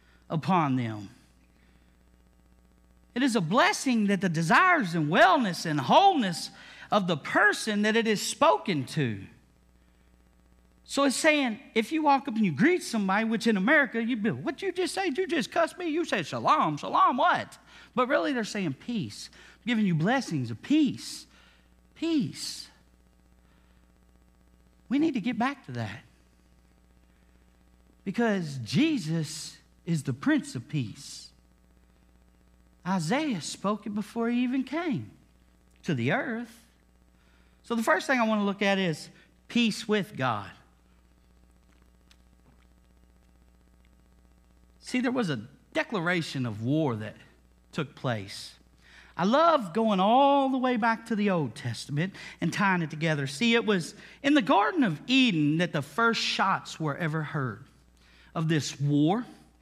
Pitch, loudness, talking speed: 160 Hz, -27 LUFS, 145 wpm